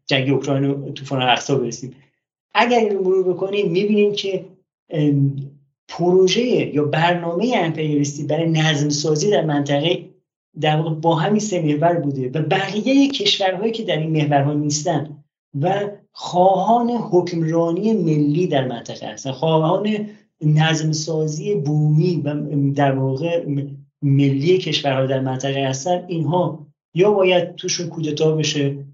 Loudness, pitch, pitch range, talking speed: -19 LUFS, 160 Hz, 145-185 Hz, 125 wpm